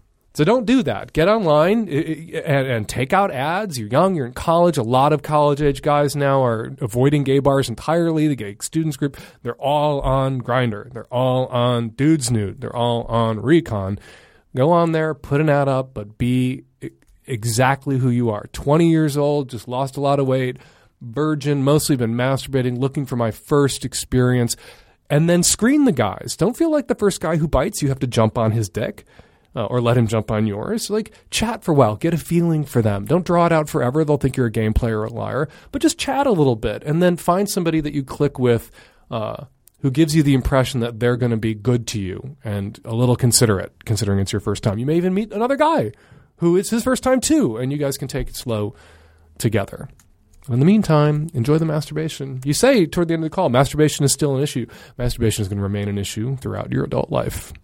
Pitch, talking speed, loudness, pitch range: 135 Hz, 220 wpm, -19 LUFS, 120-160 Hz